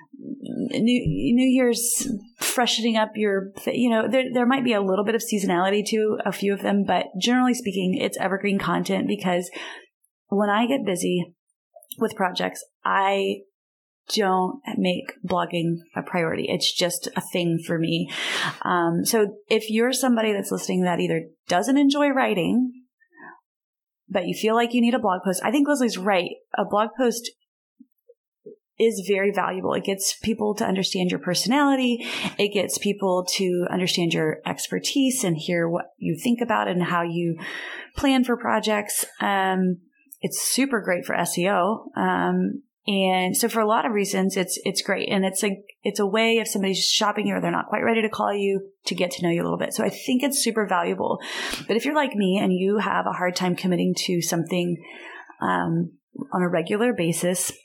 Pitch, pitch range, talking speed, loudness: 200 Hz, 180-240 Hz, 180 wpm, -23 LUFS